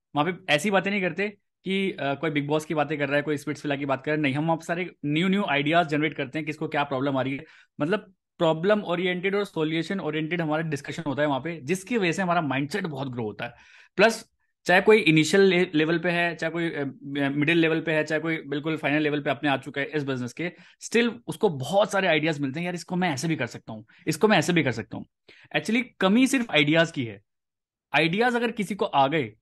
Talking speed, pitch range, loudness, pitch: 245 wpm, 145-185 Hz, -25 LUFS, 160 Hz